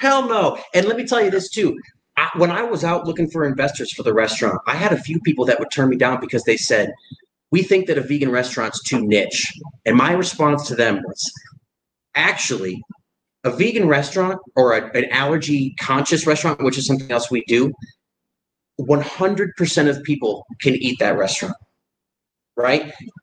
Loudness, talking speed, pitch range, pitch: -19 LUFS, 185 wpm, 130-180 Hz, 150 Hz